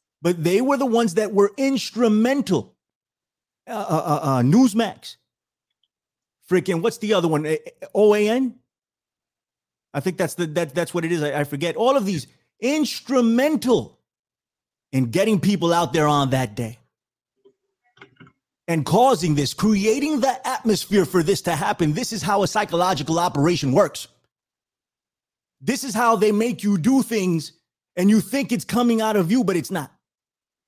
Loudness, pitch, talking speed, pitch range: -21 LUFS, 200 Hz, 155 wpm, 165-235 Hz